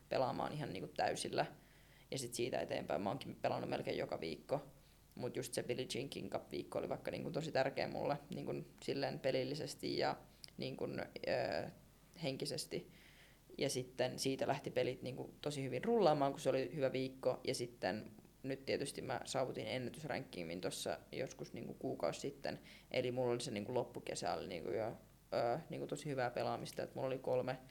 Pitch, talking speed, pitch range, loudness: 130 Hz, 165 wpm, 125-140 Hz, -42 LUFS